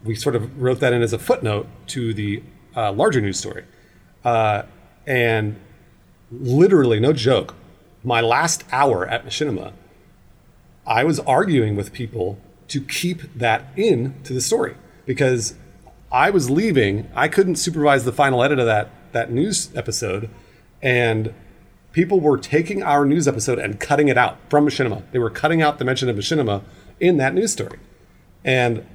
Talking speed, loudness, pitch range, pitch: 160 wpm, -19 LUFS, 105-145 Hz, 120 Hz